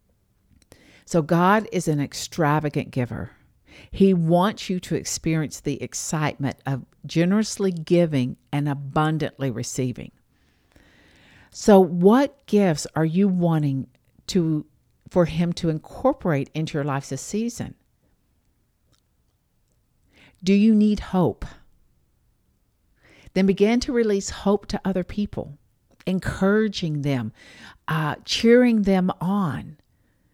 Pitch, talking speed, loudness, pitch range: 160 Hz, 105 wpm, -22 LUFS, 135-195 Hz